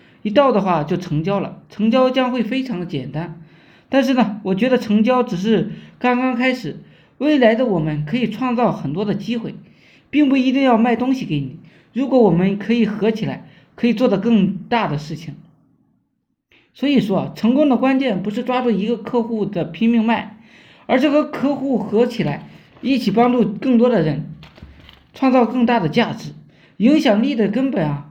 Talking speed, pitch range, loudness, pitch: 265 characters per minute, 190-250 Hz, -18 LUFS, 230 Hz